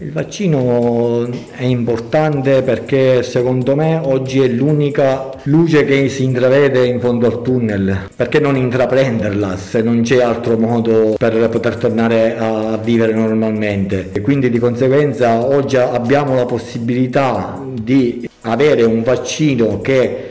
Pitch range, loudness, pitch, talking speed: 115-135 Hz, -14 LUFS, 125 Hz, 135 wpm